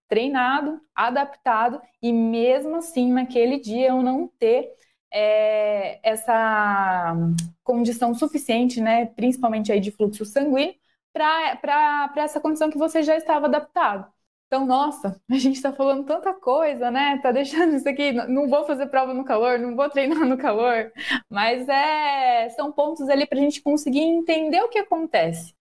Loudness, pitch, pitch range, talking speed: -22 LUFS, 280 Hz, 240-310 Hz, 150 wpm